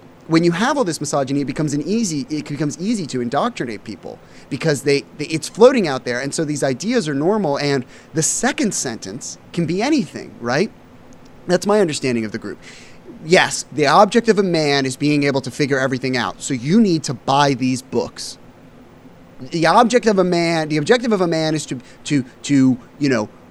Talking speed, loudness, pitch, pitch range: 200 wpm, -18 LUFS, 150 Hz, 135-175 Hz